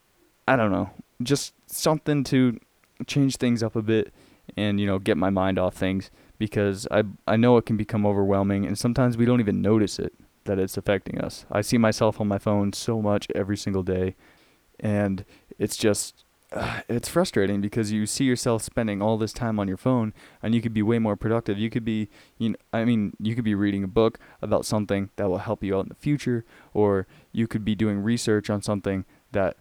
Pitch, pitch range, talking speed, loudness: 105 Hz, 100-115 Hz, 215 wpm, -25 LUFS